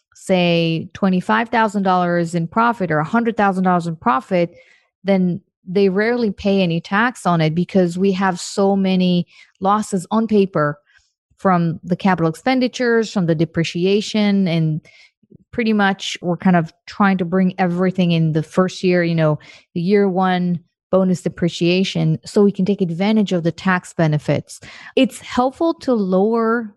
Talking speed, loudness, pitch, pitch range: 145 wpm, -18 LUFS, 185 Hz, 175-205 Hz